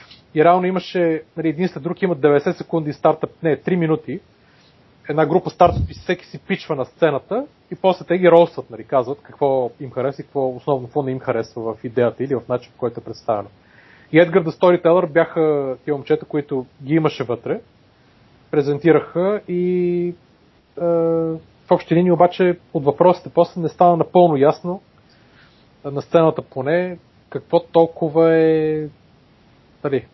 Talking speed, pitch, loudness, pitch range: 160 wpm, 160 Hz, -19 LUFS, 135-175 Hz